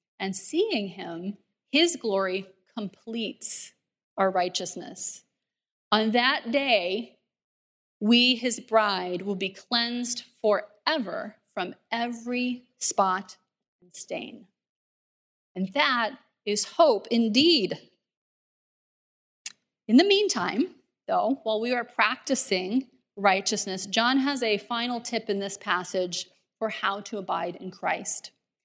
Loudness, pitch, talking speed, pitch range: -26 LUFS, 220 Hz, 105 wpm, 195-245 Hz